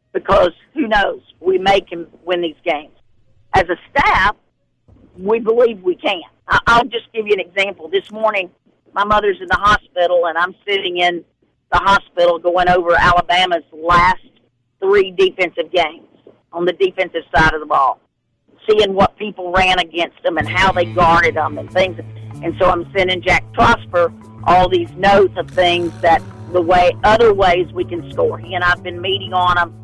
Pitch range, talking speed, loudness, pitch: 170-205 Hz, 175 wpm, -15 LUFS, 180 Hz